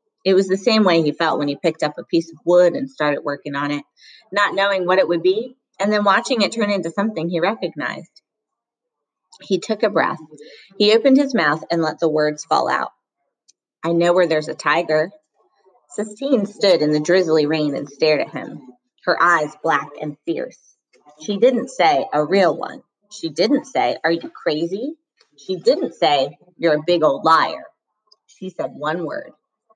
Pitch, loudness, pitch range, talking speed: 180 Hz, -19 LUFS, 155-215 Hz, 190 wpm